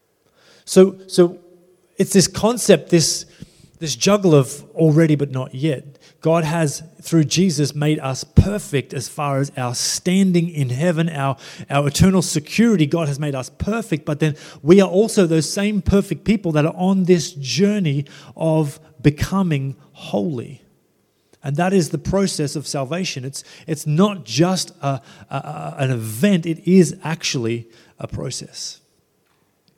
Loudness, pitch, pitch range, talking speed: -19 LUFS, 160 Hz, 145-180 Hz, 145 wpm